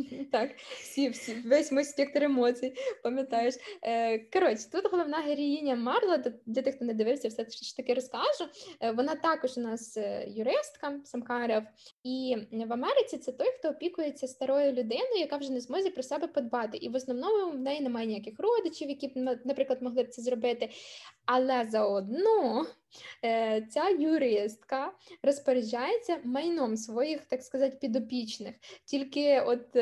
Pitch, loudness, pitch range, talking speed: 260 Hz, -31 LUFS, 240-295 Hz, 145 wpm